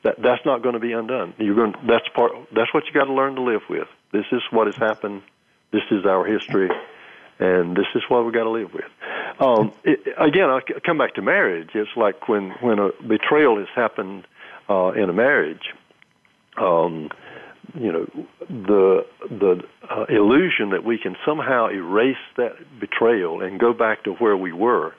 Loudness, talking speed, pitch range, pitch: -20 LUFS, 190 wpm, 105-135 Hz, 115 Hz